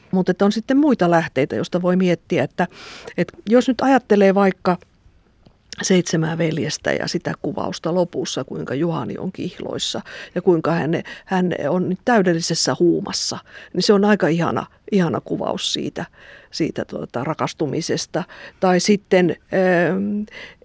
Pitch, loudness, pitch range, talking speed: 180 Hz, -20 LUFS, 165-200 Hz, 135 wpm